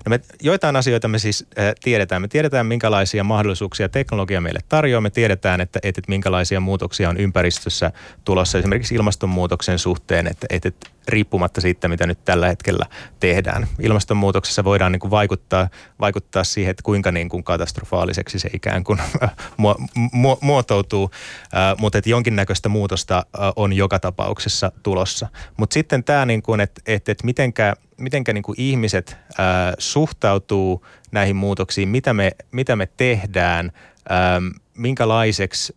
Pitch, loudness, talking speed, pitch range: 100 Hz, -19 LUFS, 150 wpm, 95-110 Hz